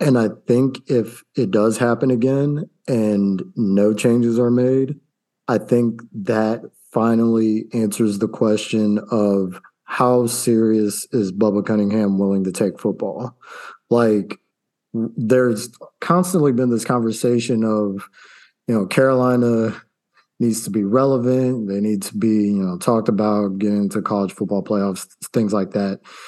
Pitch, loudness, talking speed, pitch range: 110 Hz, -19 LUFS, 135 wpm, 105-120 Hz